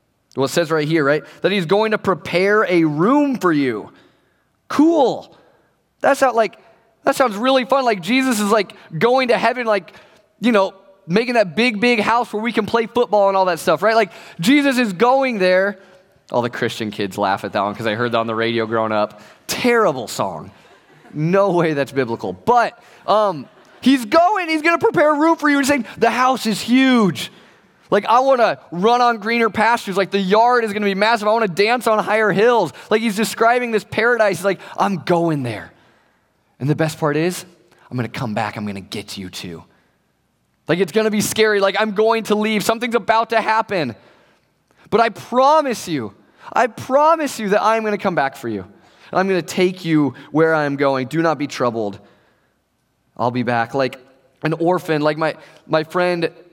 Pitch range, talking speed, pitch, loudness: 155-230 Hz, 205 wpm, 200 Hz, -17 LUFS